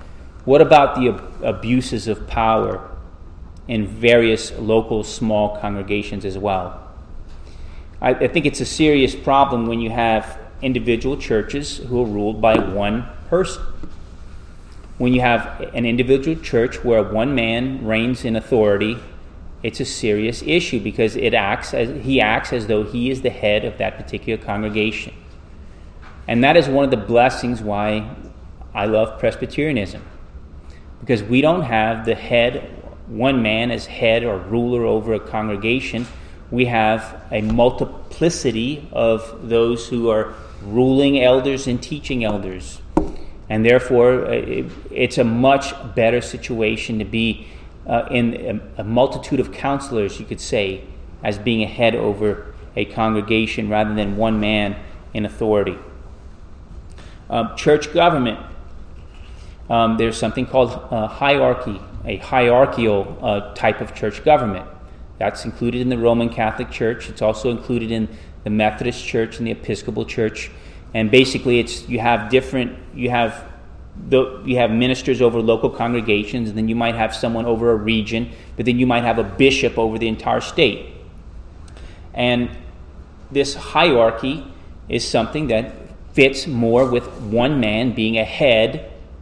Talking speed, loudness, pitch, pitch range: 145 wpm, -19 LUFS, 110 Hz, 100-120 Hz